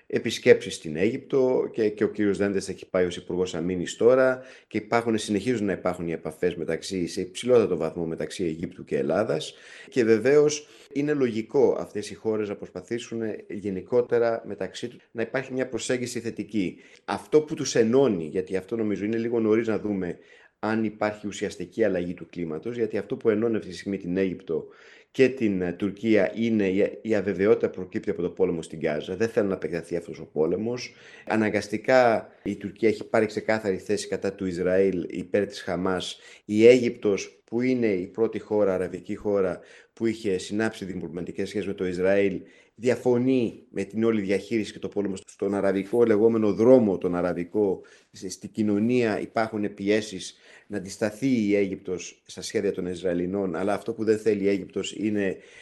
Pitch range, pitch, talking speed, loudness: 95-115 Hz, 105 Hz, 170 wpm, -26 LUFS